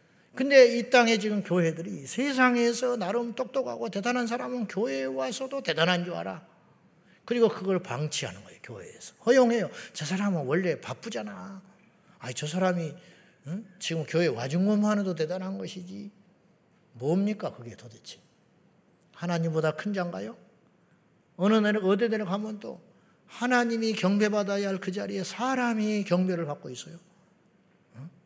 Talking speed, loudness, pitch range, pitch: 310 characters per minute, -27 LUFS, 175-220 Hz, 195 Hz